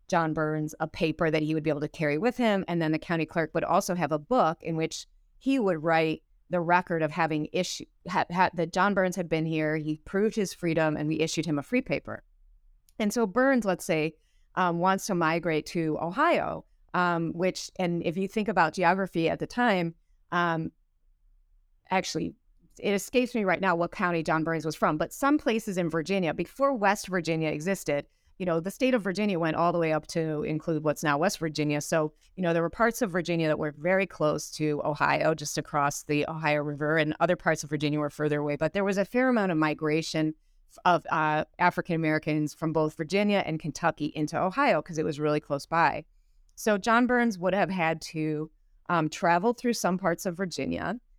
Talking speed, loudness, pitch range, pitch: 210 wpm, -28 LUFS, 155-190 Hz, 165 Hz